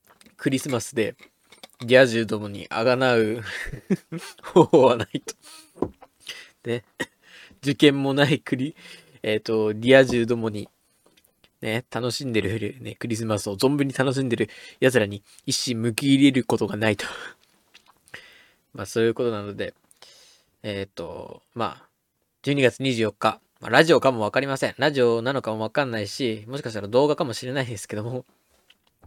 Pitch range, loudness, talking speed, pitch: 110-135 Hz, -23 LUFS, 295 characters per minute, 120 Hz